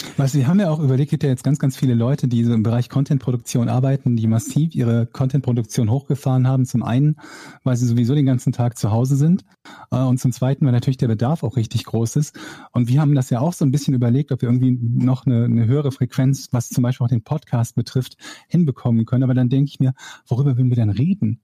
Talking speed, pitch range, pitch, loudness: 240 wpm, 120-140 Hz, 130 Hz, -19 LUFS